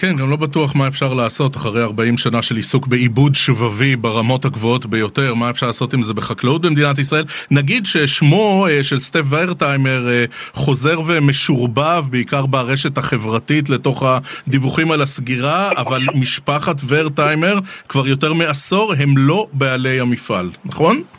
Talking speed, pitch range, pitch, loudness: 140 wpm, 125-150 Hz, 135 Hz, -15 LUFS